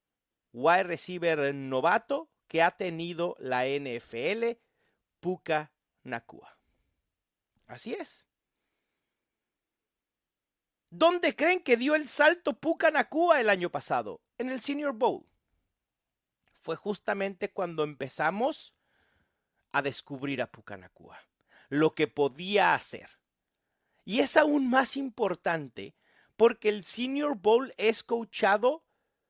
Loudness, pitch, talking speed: -28 LUFS, 205 Hz, 105 wpm